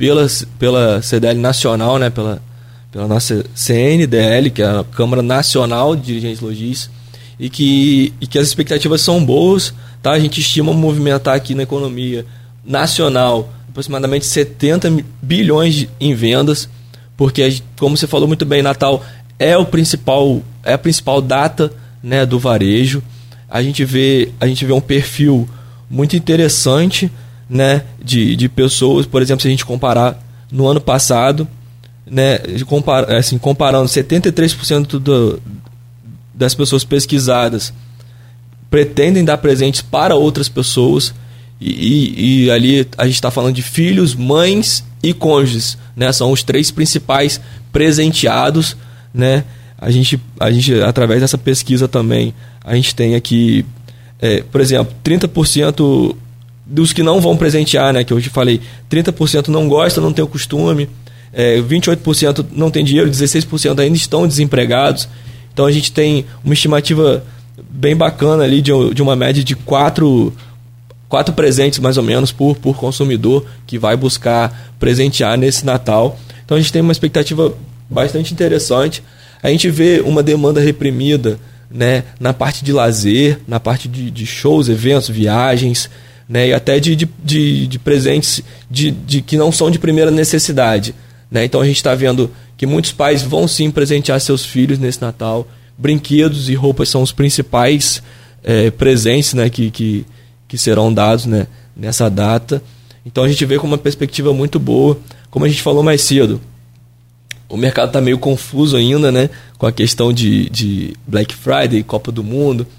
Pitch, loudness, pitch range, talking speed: 130 Hz, -13 LUFS, 120-145 Hz, 155 wpm